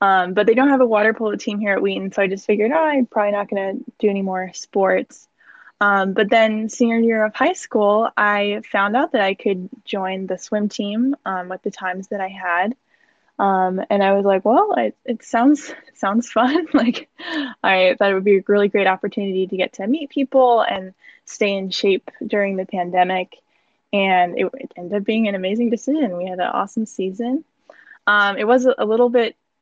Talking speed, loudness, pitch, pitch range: 210 wpm, -19 LUFS, 210 Hz, 195-245 Hz